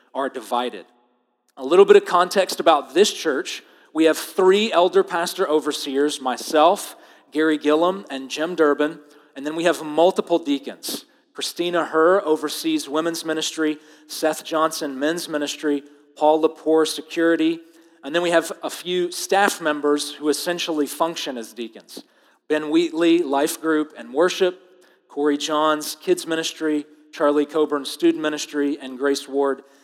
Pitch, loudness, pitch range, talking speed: 155 Hz, -21 LUFS, 145-170 Hz, 140 wpm